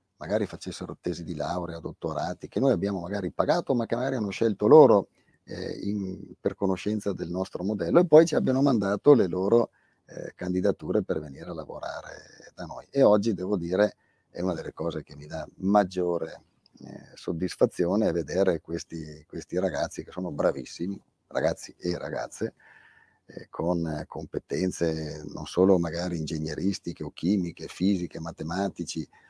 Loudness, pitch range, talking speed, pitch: -27 LUFS, 85-100 Hz, 150 wpm, 90 Hz